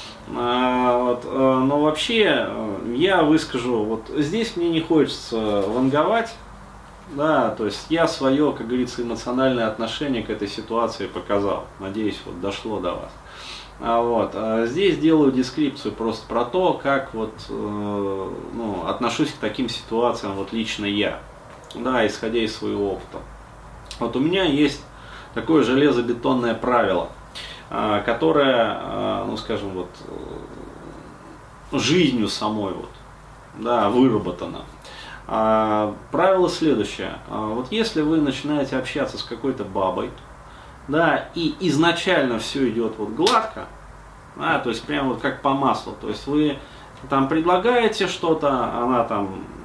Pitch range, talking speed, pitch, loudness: 110-145 Hz, 125 wpm, 120 Hz, -22 LUFS